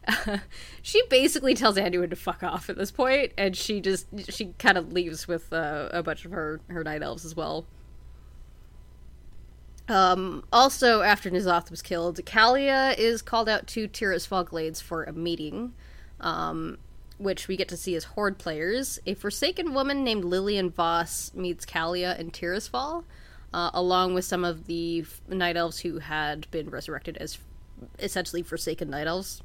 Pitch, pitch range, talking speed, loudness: 180 Hz, 165-205 Hz, 165 wpm, -27 LUFS